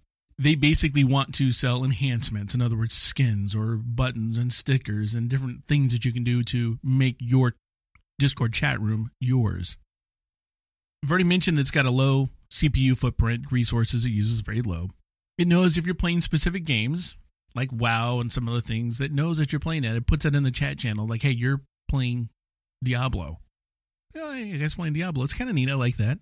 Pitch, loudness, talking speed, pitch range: 125 Hz, -25 LUFS, 195 wpm, 115-140 Hz